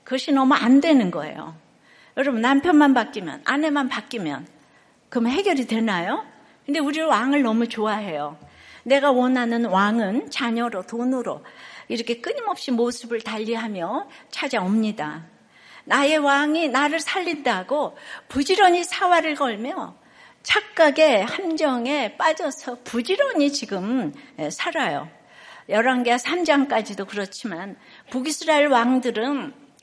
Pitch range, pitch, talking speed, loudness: 230-300 Hz, 265 Hz, 270 characters per minute, -22 LUFS